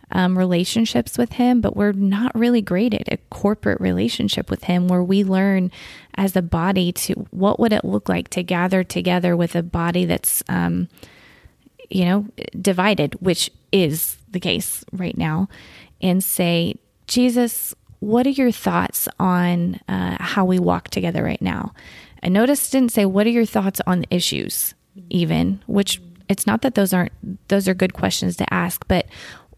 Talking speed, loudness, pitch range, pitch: 170 wpm, -20 LUFS, 175-210 Hz, 190 Hz